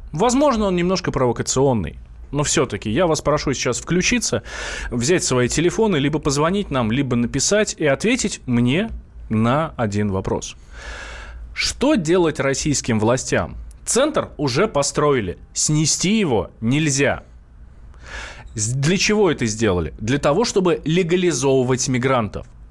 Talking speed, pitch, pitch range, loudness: 115 wpm, 140 Hz, 115-170 Hz, -19 LUFS